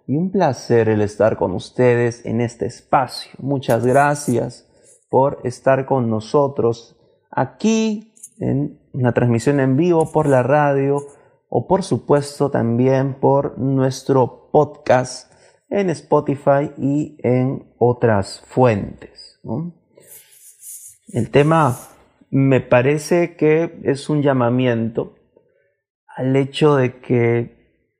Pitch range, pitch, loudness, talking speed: 125-150 Hz, 135 Hz, -18 LUFS, 110 wpm